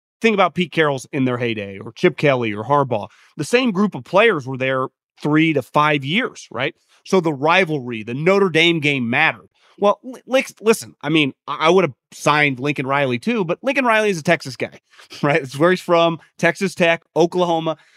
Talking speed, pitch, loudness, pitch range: 195 wpm, 160 Hz, -18 LUFS, 140-185 Hz